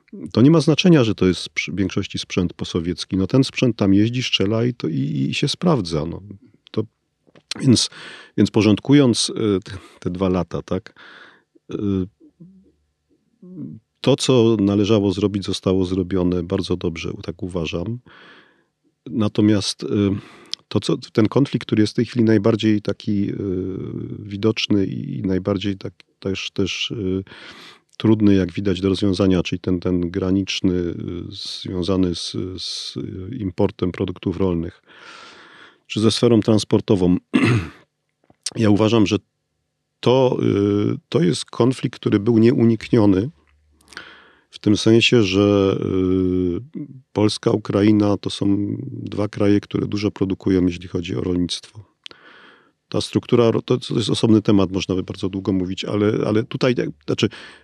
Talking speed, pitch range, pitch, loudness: 125 wpm, 95-110 Hz, 100 Hz, -20 LUFS